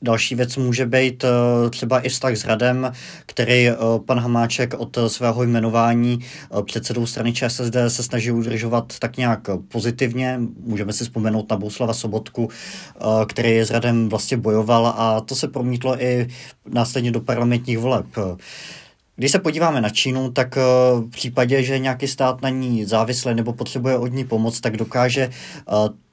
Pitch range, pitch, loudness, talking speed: 115-130 Hz, 120 Hz, -20 LUFS, 150 wpm